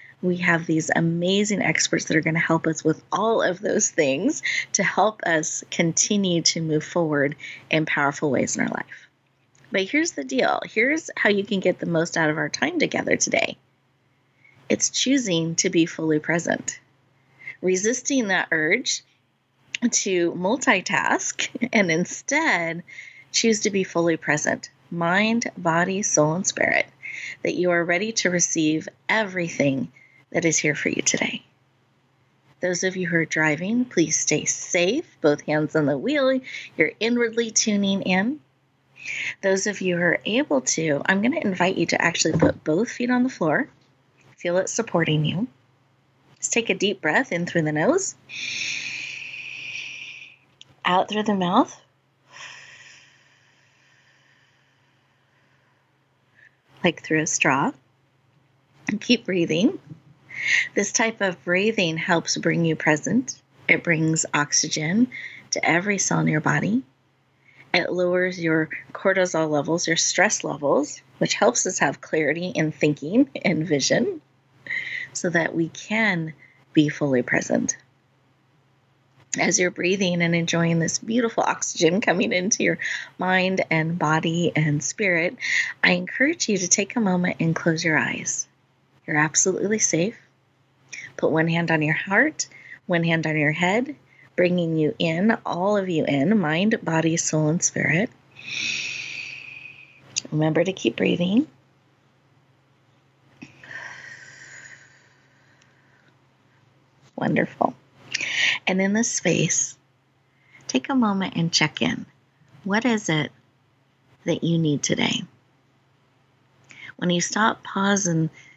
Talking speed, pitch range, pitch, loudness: 135 wpm, 145-195 Hz, 165 Hz, -22 LUFS